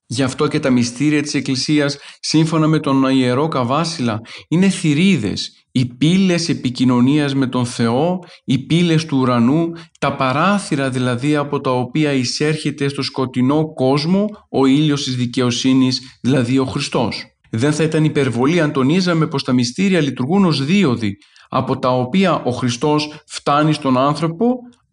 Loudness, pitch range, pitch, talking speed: -17 LUFS, 130-155 Hz, 140 Hz, 145 wpm